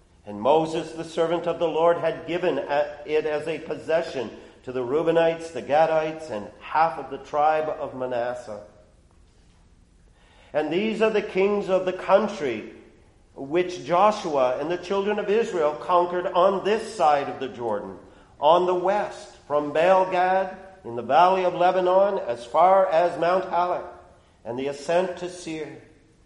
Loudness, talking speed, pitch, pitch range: -23 LUFS, 155 wpm, 160 Hz, 130-180 Hz